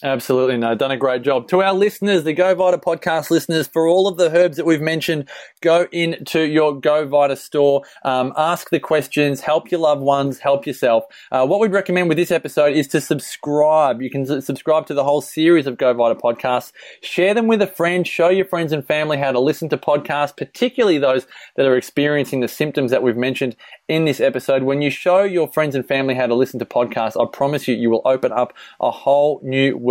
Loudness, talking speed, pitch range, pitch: -18 LUFS, 220 wpm, 135-165 Hz, 150 Hz